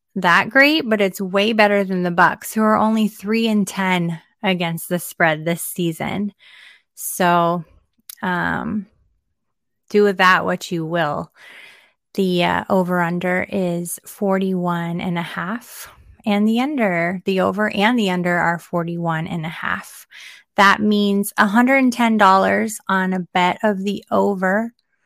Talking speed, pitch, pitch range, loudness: 145 wpm, 190 Hz, 175-210 Hz, -18 LUFS